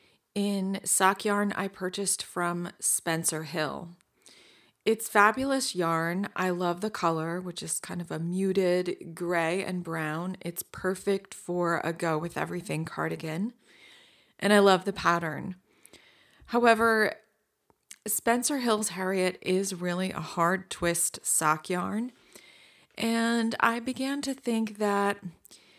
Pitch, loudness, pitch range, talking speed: 185 Hz, -28 LUFS, 175-210 Hz, 125 wpm